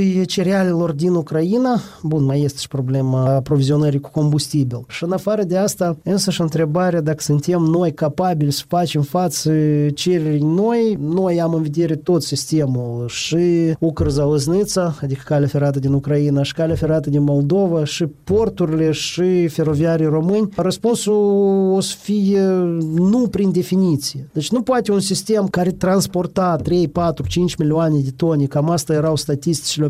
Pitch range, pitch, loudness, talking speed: 150-185 Hz, 165 Hz, -18 LUFS, 150 wpm